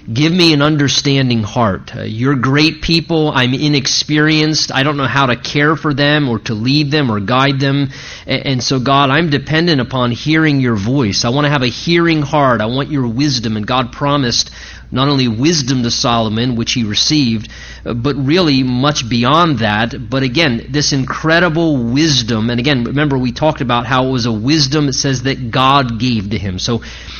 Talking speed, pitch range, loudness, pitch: 190 wpm, 120-150 Hz, -13 LUFS, 135 Hz